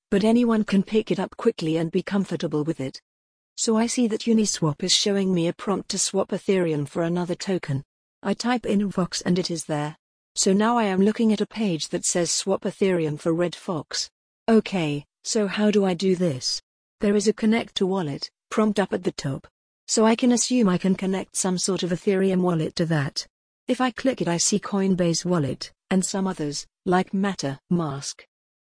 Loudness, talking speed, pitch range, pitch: -24 LUFS, 200 wpm, 170-210 Hz, 190 Hz